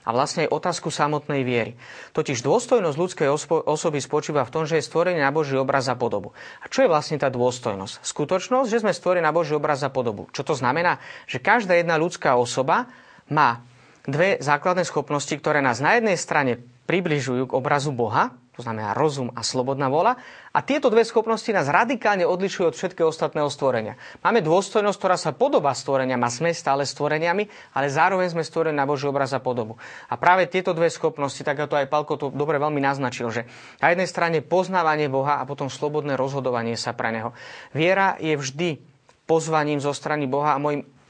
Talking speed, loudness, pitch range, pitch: 190 wpm, -23 LUFS, 135-170 Hz, 150 Hz